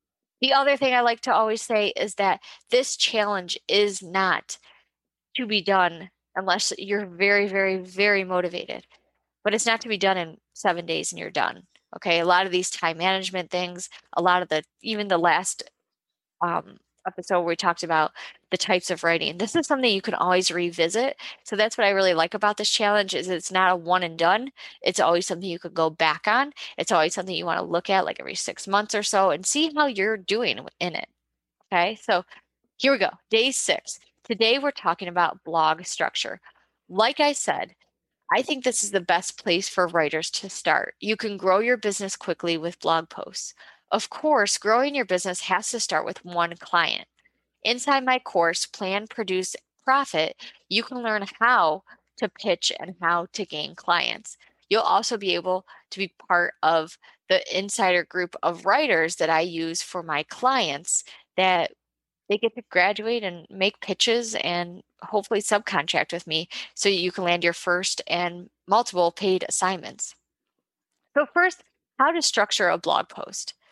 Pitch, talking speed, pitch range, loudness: 190 Hz, 185 wpm, 175-220 Hz, -24 LUFS